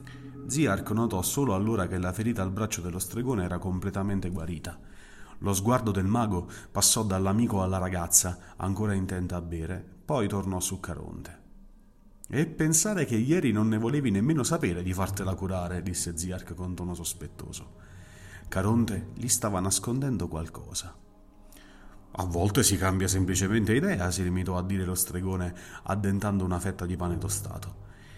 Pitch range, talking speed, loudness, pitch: 90-110 Hz, 150 wpm, -28 LUFS, 95 Hz